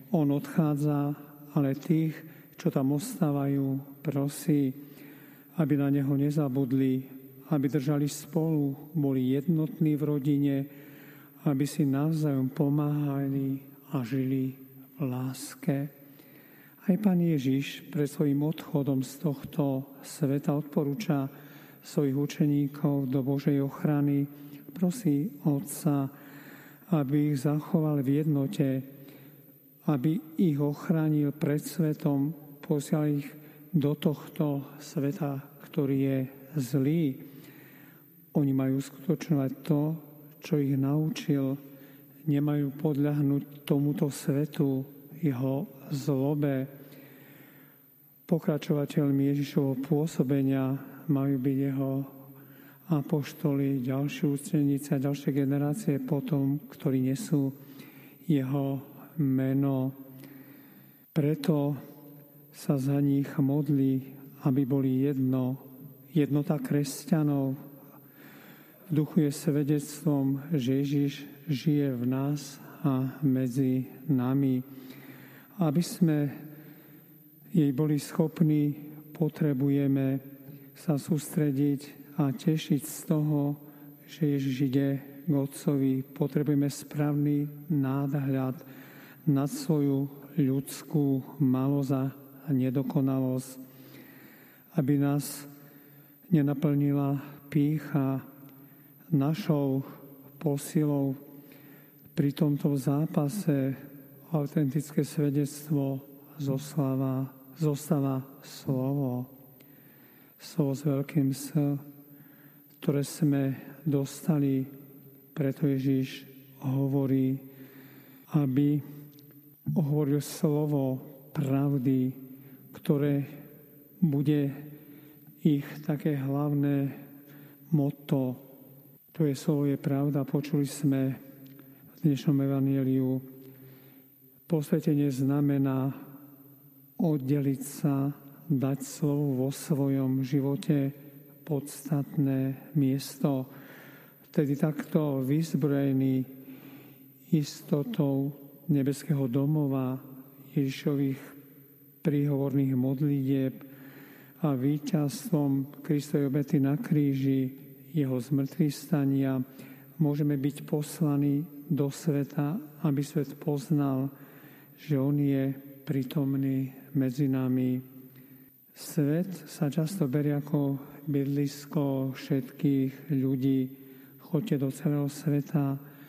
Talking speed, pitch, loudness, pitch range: 80 wpm, 140 Hz, -29 LUFS, 135-150 Hz